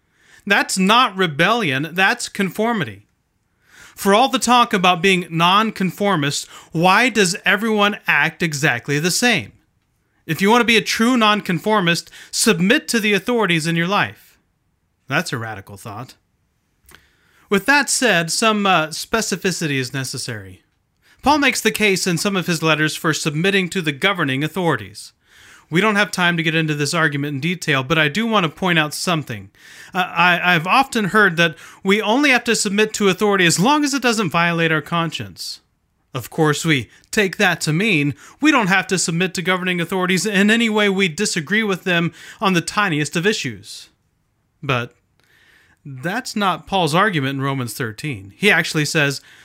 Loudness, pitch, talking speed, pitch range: -17 LUFS, 180 Hz, 170 wpm, 155-210 Hz